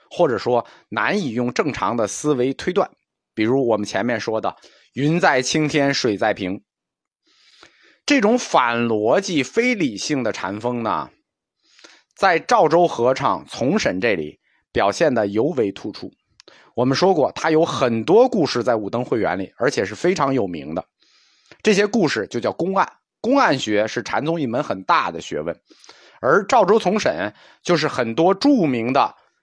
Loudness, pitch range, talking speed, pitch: -20 LUFS, 125-190 Hz, 230 characters per minute, 150 Hz